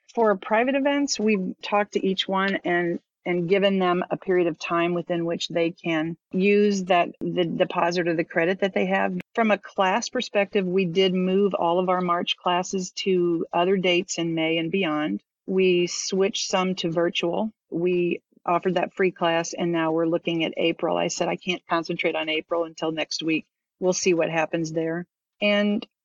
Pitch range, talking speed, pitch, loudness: 170-195 Hz, 185 wpm, 180 Hz, -24 LUFS